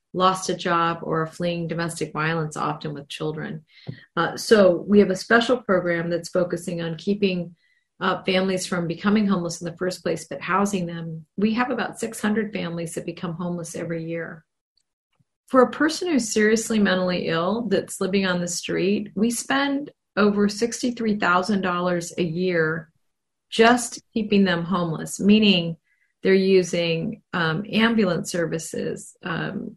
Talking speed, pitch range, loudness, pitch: 145 wpm, 170-215 Hz, -23 LUFS, 185 Hz